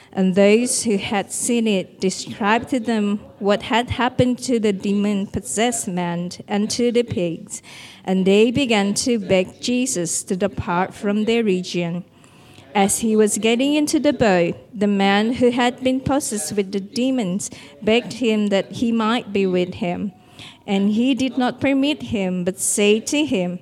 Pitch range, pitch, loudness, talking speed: 195-240 Hz, 210 Hz, -20 LUFS, 170 wpm